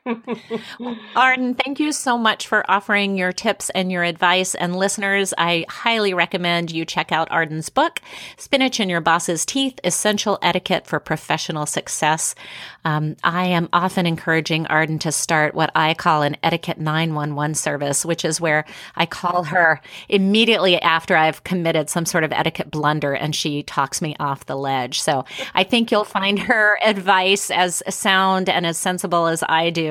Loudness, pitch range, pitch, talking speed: -19 LUFS, 160-200 Hz, 175 Hz, 170 wpm